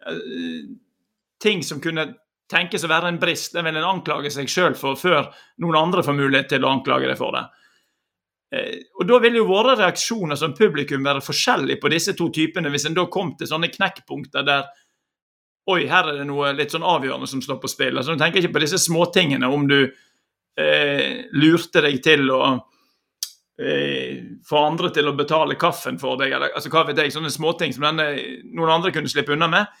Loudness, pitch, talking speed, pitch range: -20 LUFS, 155 Hz, 195 wpm, 145-180 Hz